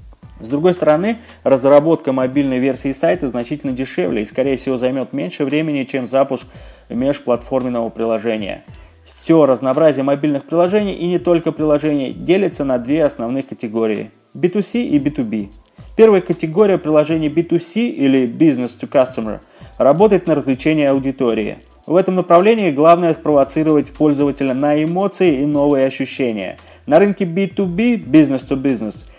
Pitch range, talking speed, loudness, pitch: 130-170 Hz, 130 wpm, -16 LUFS, 145 Hz